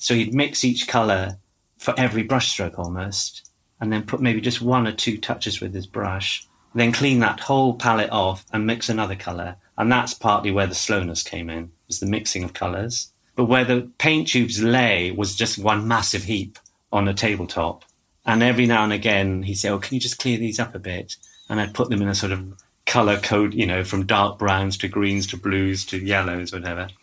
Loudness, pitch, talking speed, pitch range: -22 LUFS, 105 Hz, 220 wpm, 95-120 Hz